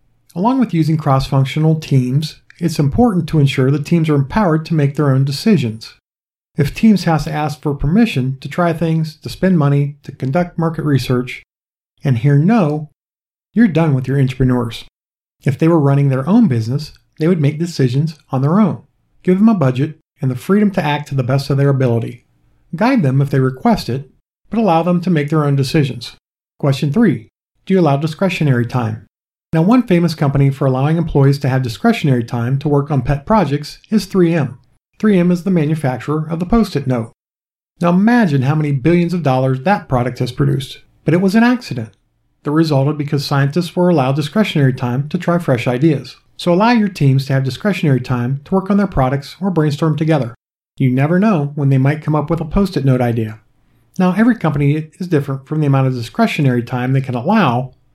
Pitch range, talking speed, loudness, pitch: 135-175 Hz, 200 wpm, -15 LUFS, 145 Hz